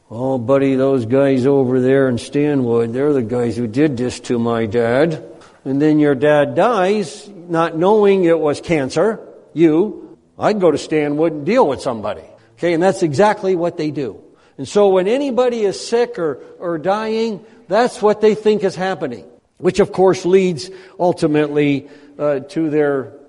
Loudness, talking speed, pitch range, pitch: -16 LUFS, 170 wpm, 140-190 Hz, 155 Hz